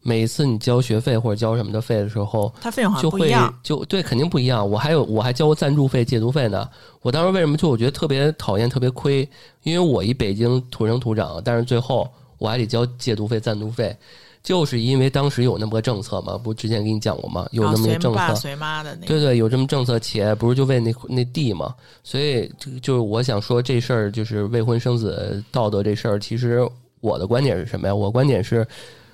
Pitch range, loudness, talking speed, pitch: 110-135 Hz, -21 LUFS, 340 characters per minute, 120 Hz